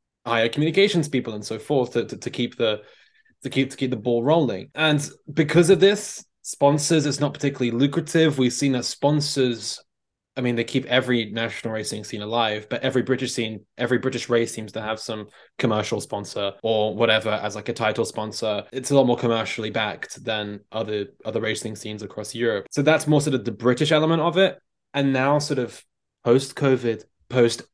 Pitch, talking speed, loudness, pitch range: 125 Hz, 195 wpm, -23 LUFS, 110-145 Hz